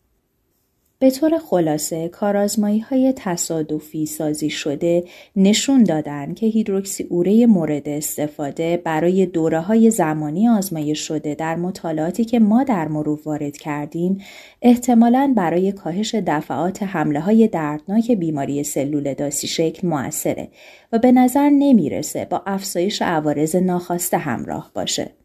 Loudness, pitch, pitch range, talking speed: -19 LUFS, 175 Hz, 155-220 Hz, 120 wpm